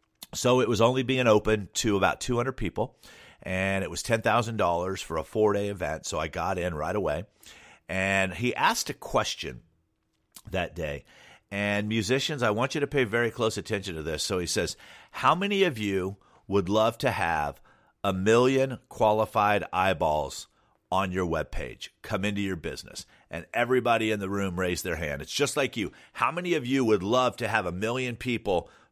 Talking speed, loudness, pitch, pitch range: 185 wpm, -27 LUFS, 110 Hz, 100-125 Hz